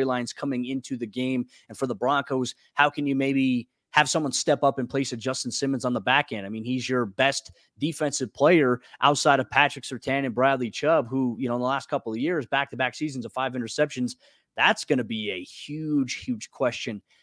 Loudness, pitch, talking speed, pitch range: -25 LUFS, 130 Hz, 225 wpm, 125-140 Hz